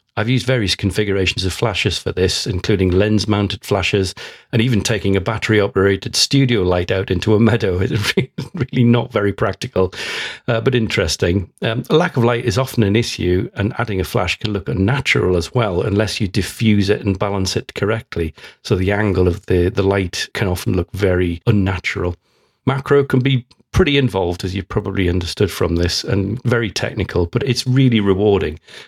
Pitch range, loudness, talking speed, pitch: 95-120 Hz, -17 LUFS, 185 wpm, 105 Hz